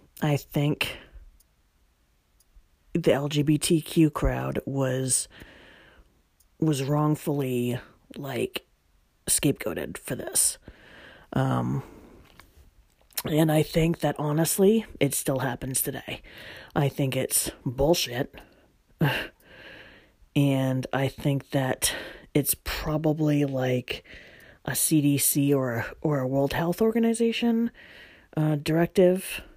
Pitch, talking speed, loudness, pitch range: 145 Hz, 85 wpm, -26 LUFS, 130-155 Hz